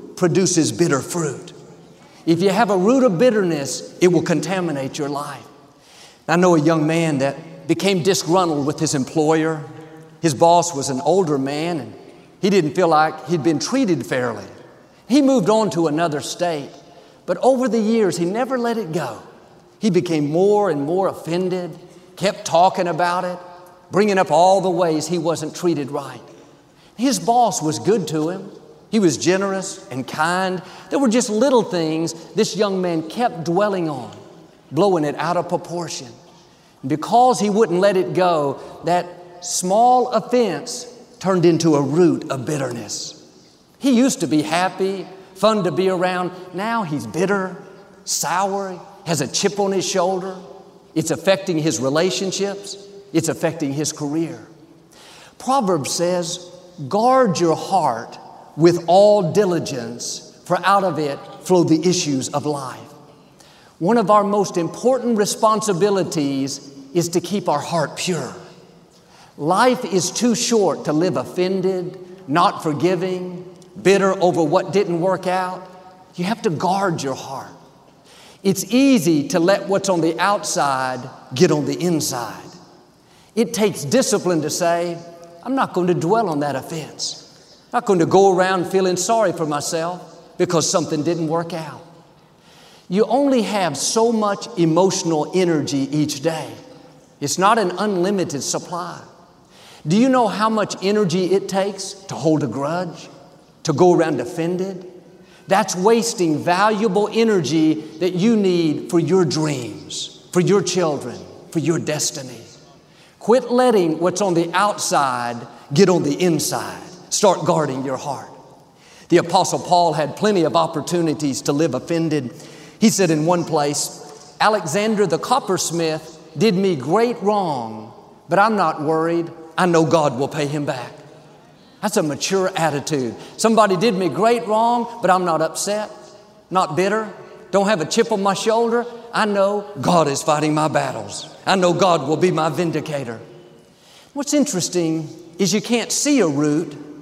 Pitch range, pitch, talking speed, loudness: 155-195 Hz, 175 Hz, 150 wpm, -19 LUFS